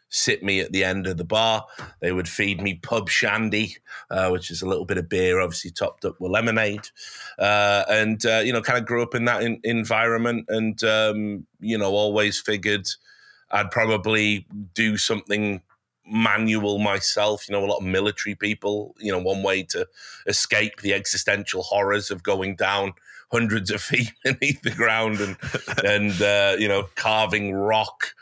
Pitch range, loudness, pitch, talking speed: 100-110 Hz, -22 LUFS, 105 Hz, 180 wpm